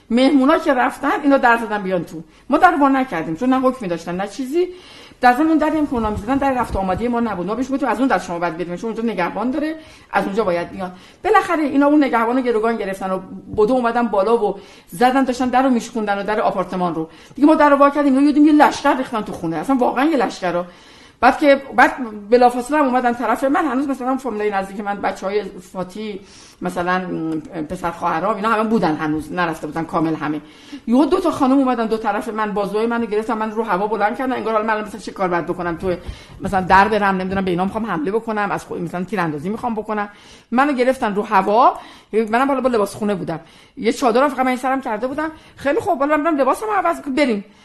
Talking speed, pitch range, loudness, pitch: 215 wpm, 190-270 Hz, -18 LUFS, 225 Hz